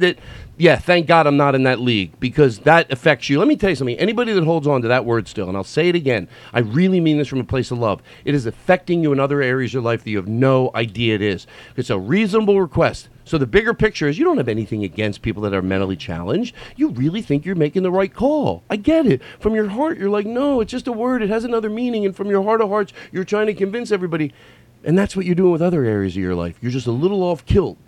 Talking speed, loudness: 280 wpm, -18 LUFS